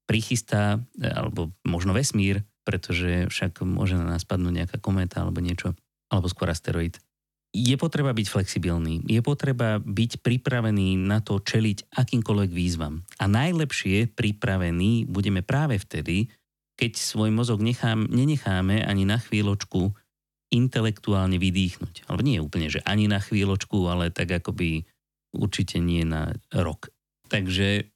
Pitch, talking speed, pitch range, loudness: 100 Hz, 130 wpm, 90-110 Hz, -25 LUFS